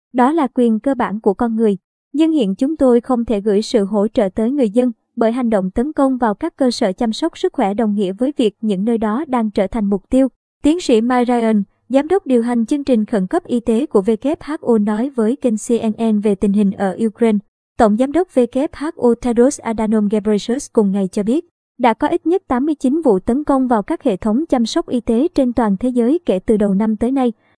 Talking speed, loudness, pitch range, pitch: 235 wpm, -17 LUFS, 220-265 Hz, 240 Hz